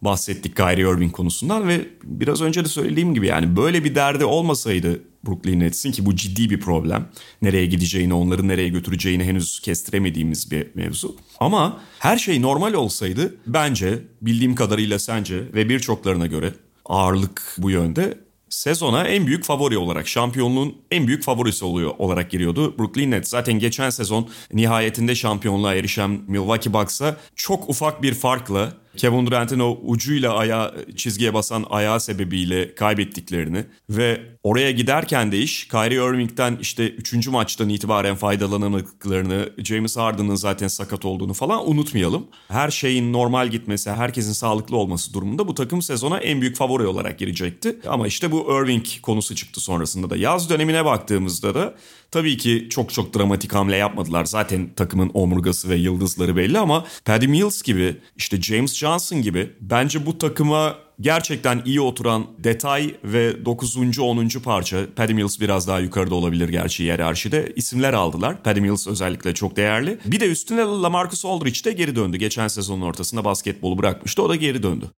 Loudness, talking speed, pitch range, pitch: -21 LUFS, 155 wpm, 95-130 Hz, 110 Hz